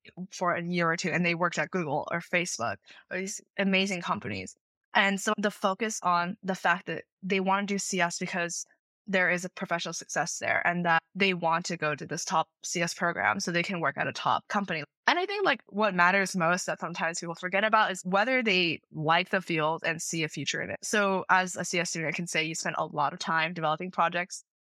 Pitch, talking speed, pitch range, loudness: 175 Hz, 230 wpm, 165-195 Hz, -28 LUFS